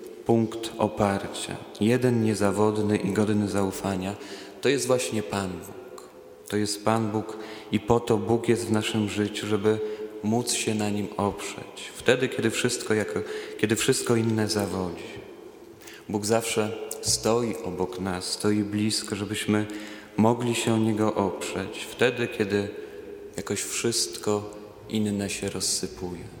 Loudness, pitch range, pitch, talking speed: -26 LUFS, 105-115 Hz, 105 Hz, 130 wpm